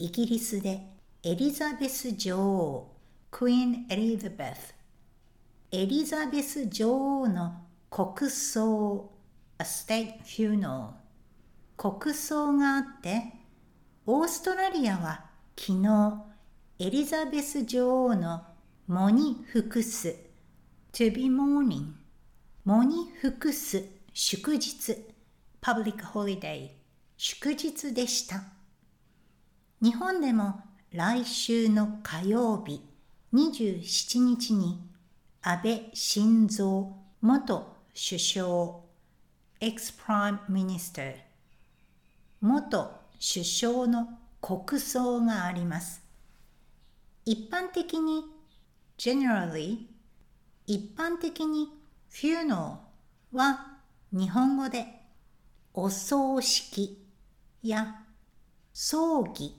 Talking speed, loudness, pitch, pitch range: 180 characters per minute, -29 LUFS, 220 Hz, 190-260 Hz